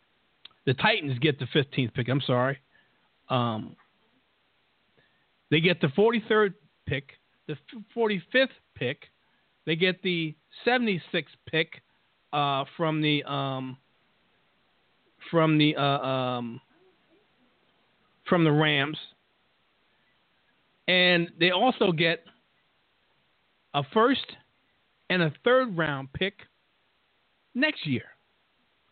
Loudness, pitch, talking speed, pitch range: -26 LUFS, 155 Hz, 100 wpm, 140-185 Hz